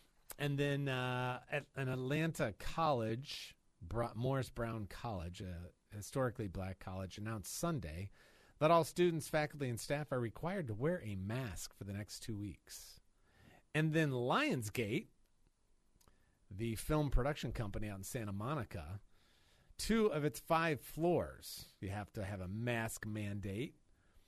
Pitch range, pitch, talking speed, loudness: 100-145 Hz, 115 Hz, 140 wpm, -40 LUFS